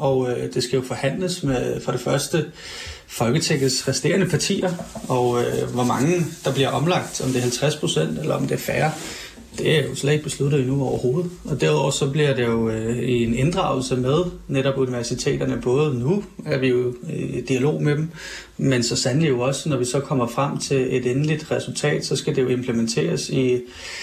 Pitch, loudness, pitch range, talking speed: 135 Hz, -22 LUFS, 125-150 Hz, 190 wpm